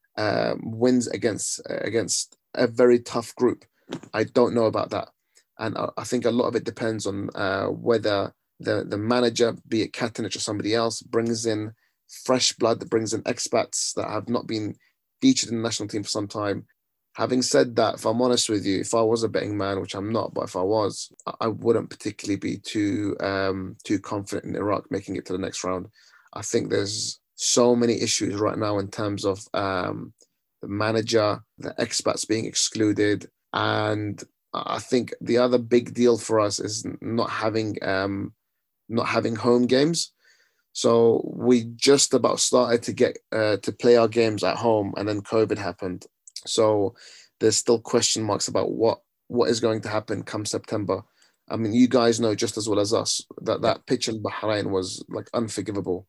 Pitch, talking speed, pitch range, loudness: 110 Hz, 190 wpm, 105-120 Hz, -24 LUFS